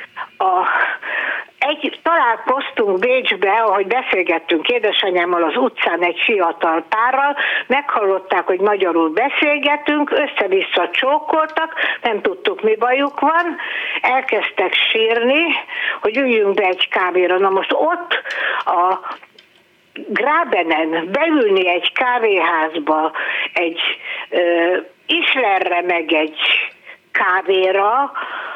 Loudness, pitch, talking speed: -16 LUFS, 235 Hz, 90 wpm